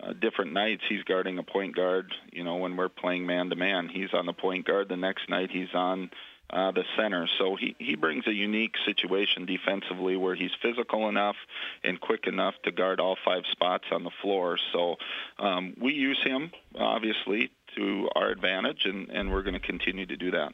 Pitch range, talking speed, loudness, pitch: 90-105 Hz, 200 wpm, -29 LUFS, 95 Hz